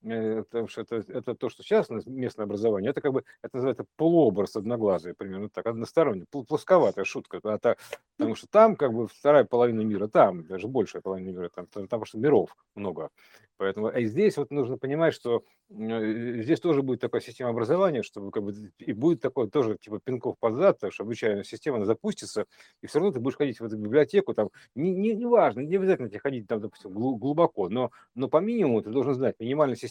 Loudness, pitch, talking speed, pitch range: -27 LUFS, 120 Hz, 205 wpm, 110-155 Hz